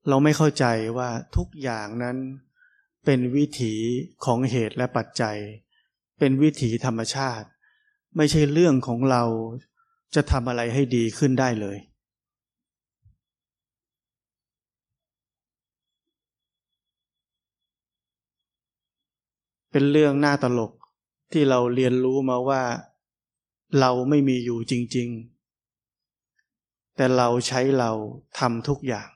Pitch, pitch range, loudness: 125 Hz, 120-140 Hz, -23 LUFS